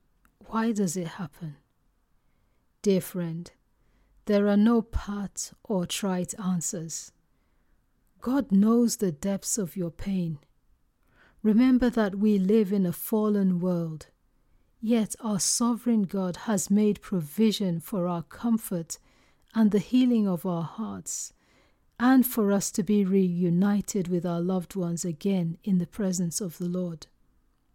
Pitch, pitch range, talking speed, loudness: 195 Hz, 175-215 Hz, 130 wpm, -27 LUFS